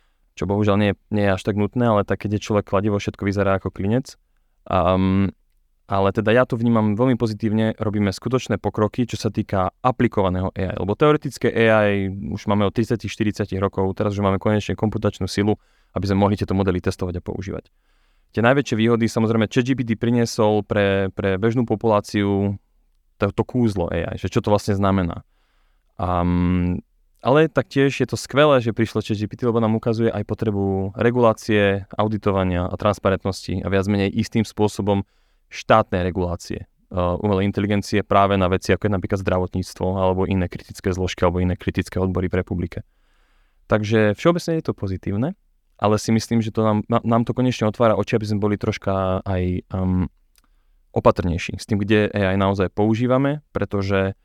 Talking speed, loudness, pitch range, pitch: 165 wpm, -21 LUFS, 95-110 Hz, 105 Hz